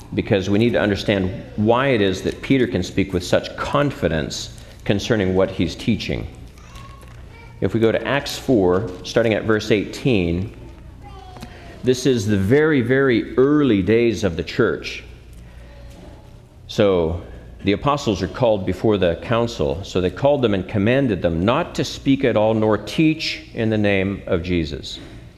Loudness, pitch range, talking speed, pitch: -19 LUFS, 95-120 Hz, 155 wpm, 105 Hz